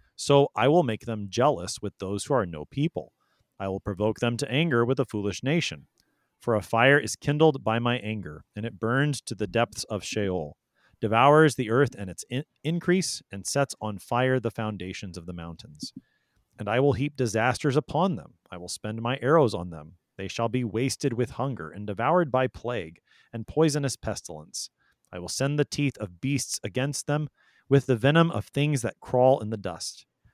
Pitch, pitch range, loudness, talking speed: 120 Hz, 105-140 Hz, -26 LUFS, 200 wpm